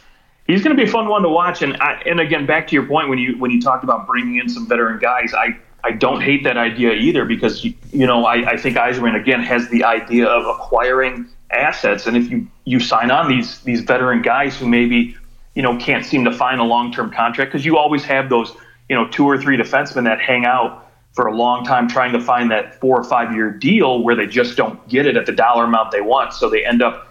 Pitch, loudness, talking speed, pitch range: 125 Hz, -16 LUFS, 255 wpm, 120-145 Hz